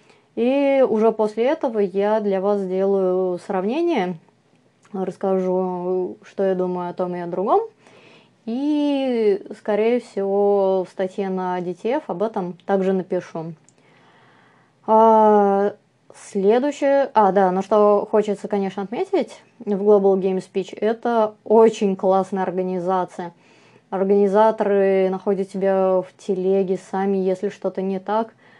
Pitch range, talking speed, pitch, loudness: 190-220 Hz, 120 wpm, 200 Hz, -20 LUFS